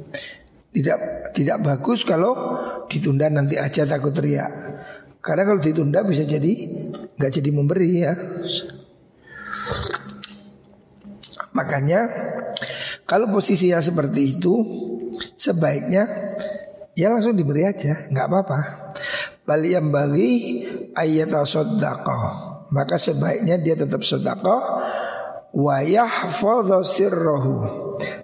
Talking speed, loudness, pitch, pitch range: 85 wpm, -21 LUFS, 165 Hz, 145-195 Hz